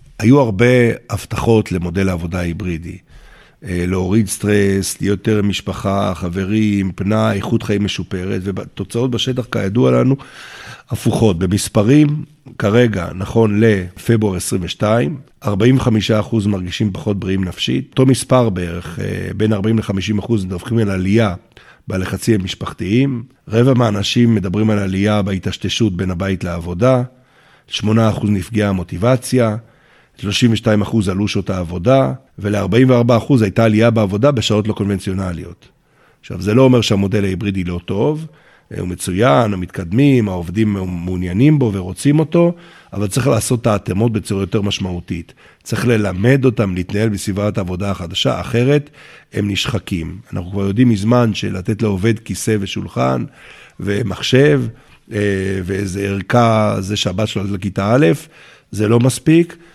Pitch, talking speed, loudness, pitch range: 105 Hz, 125 wpm, -16 LUFS, 95-120 Hz